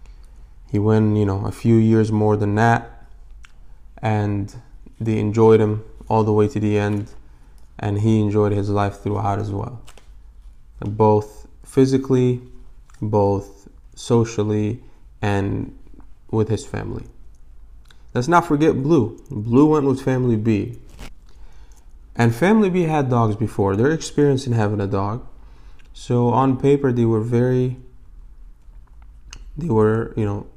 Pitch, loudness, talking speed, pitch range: 110 Hz, -19 LUFS, 130 wpm, 100-120 Hz